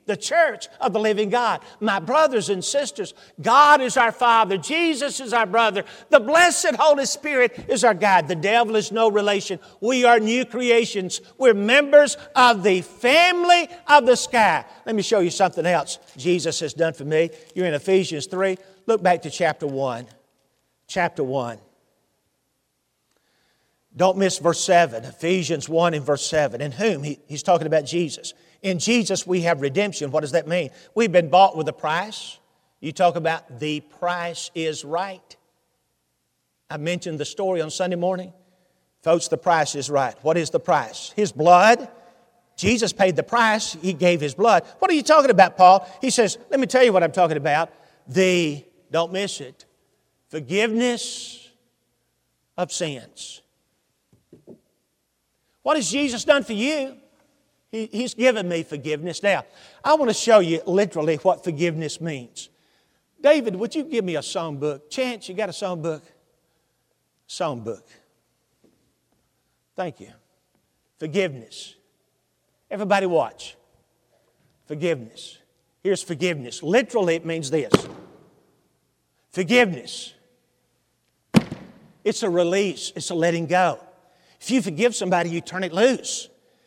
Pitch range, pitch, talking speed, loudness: 165-235 Hz, 185 Hz, 150 wpm, -20 LUFS